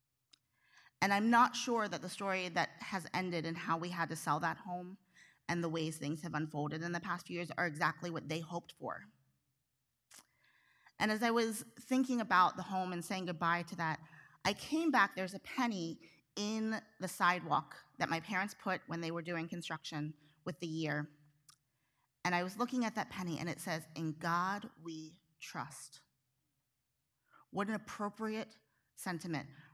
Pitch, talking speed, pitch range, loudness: 170 Hz, 175 wpm, 155-190 Hz, -37 LUFS